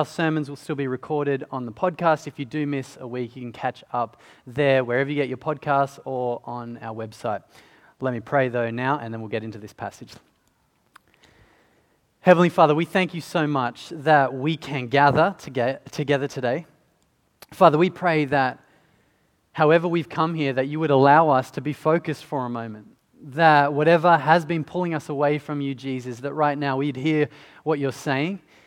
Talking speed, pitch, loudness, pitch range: 195 wpm, 145 Hz, -22 LUFS, 130-155 Hz